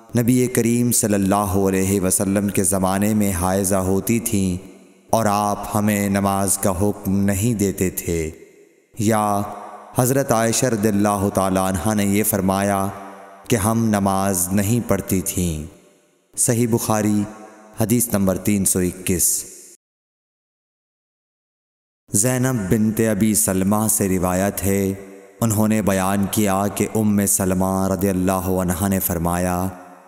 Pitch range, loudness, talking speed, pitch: 95-110 Hz, -19 LUFS, 125 wpm, 100 Hz